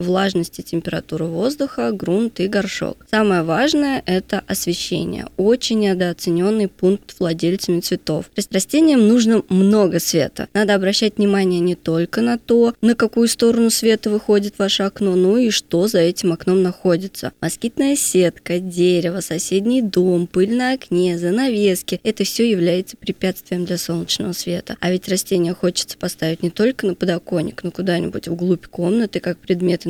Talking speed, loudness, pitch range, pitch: 150 wpm, -18 LUFS, 175-220 Hz, 190 Hz